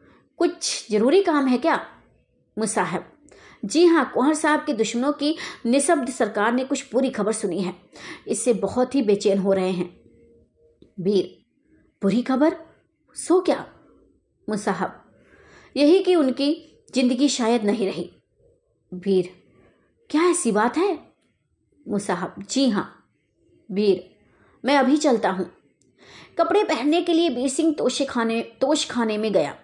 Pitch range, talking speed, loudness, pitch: 210-310 Hz, 135 wpm, -22 LUFS, 255 Hz